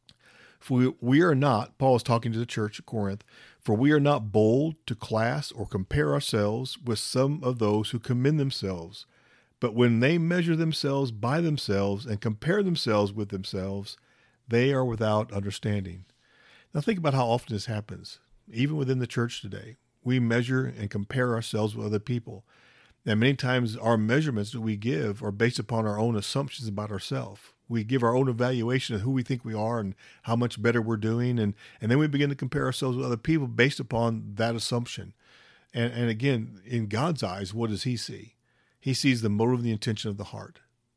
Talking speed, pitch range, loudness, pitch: 195 wpm, 110-130 Hz, -27 LUFS, 120 Hz